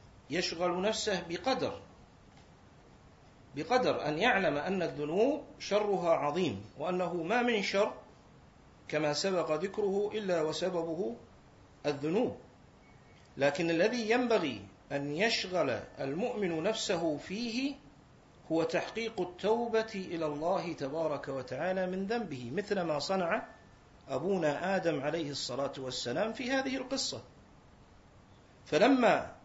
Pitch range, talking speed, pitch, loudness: 150-215 Hz, 100 wpm, 180 Hz, -33 LUFS